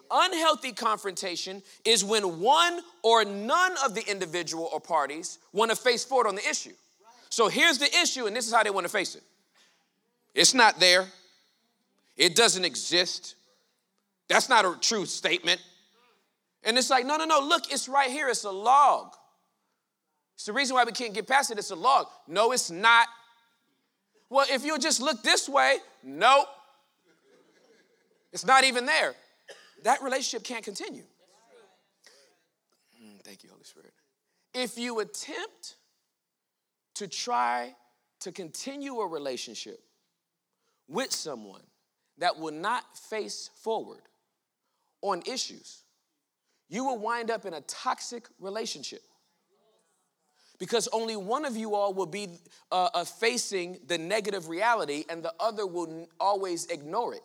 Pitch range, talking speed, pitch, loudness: 190-270 Hz, 145 wpm, 225 Hz, -26 LUFS